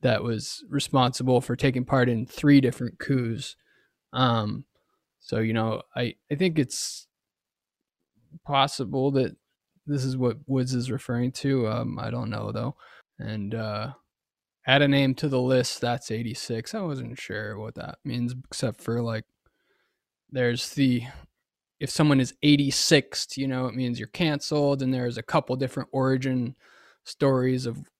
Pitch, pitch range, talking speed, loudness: 130 Hz, 120-140 Hz, 150 wpm, -26 LUFS